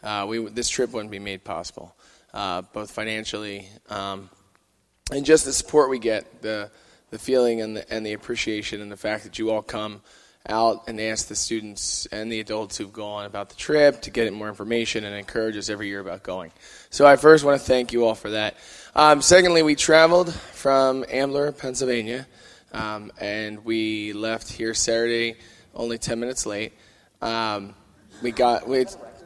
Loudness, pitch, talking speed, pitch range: -22 LUFS, 110 Hz, 185 wpm, 105-125 Hz